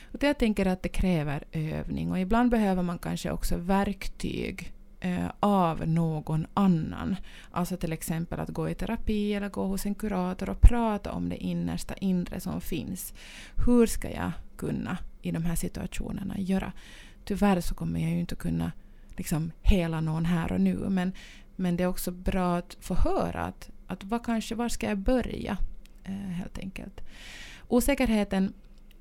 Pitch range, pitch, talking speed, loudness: 165-205 Hz, 185 Hz, 170 wpm, -29 LUFS